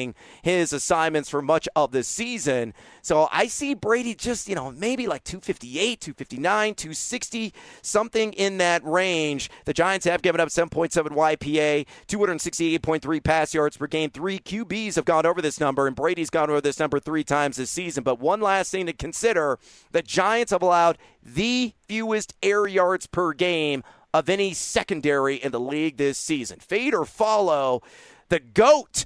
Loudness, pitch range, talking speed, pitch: -24 LUFS, 150-205 Hz, 165 wpm, 170 Hz